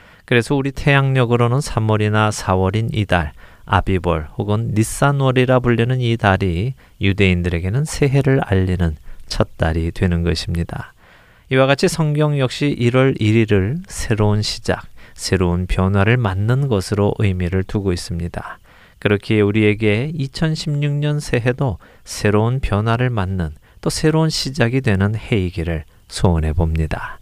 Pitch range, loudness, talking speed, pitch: 95-130 Hz, -18 LUFS, 290 characters per minute, 105 Hz